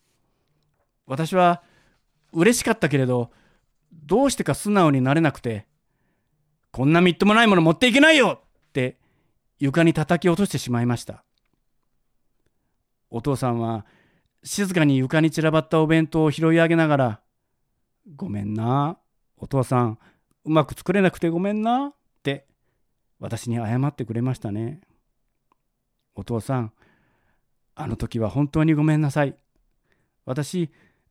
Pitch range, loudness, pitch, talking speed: 120-165 Hz, -21 LUFS, 145 Hz, 260 characters per minute